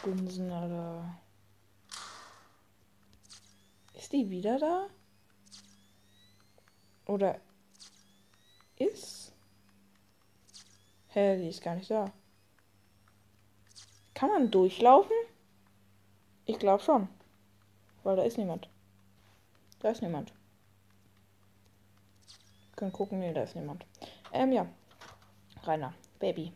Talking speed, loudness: 85 wpm, -31 LUFS